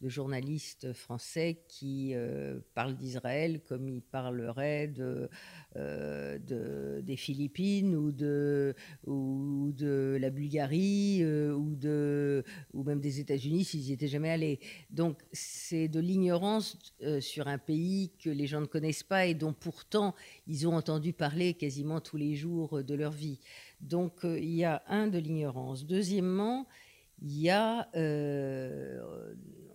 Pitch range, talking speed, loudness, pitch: 140-165 Hz, 150 wpm, -34 LUFS, 150 Hz